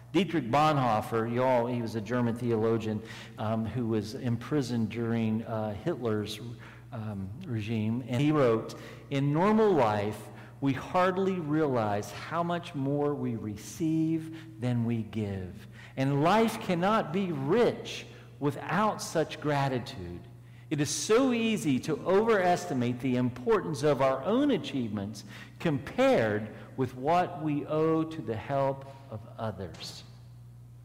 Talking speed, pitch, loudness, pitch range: 125 wpm, 125 Hz, -29 LUFS, 115-155 Hz